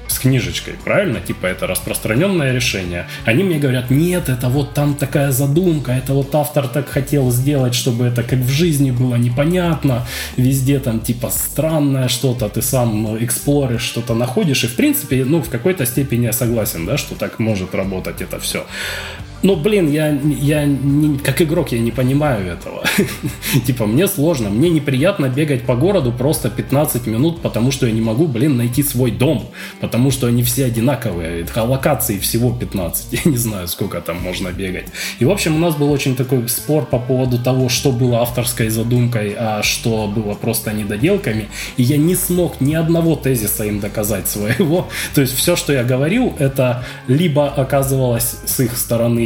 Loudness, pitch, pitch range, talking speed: -17 LUFS, 130 Hz, 115-145 Hz, 180 wpm